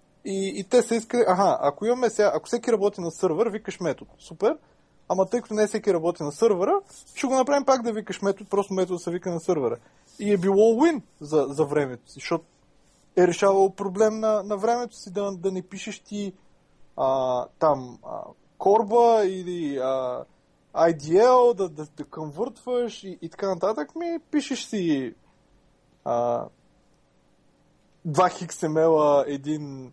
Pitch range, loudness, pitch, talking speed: 160-225 Hz, -24 LUFS, 195 Hz, 160 wpm